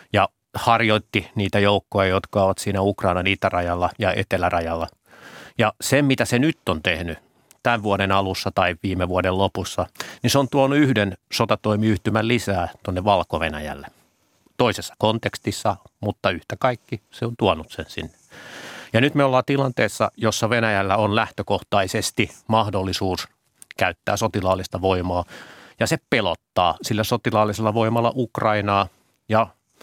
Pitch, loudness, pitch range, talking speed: 105 Hz, -21 LUFS, 95-115 Hz, 130 wpm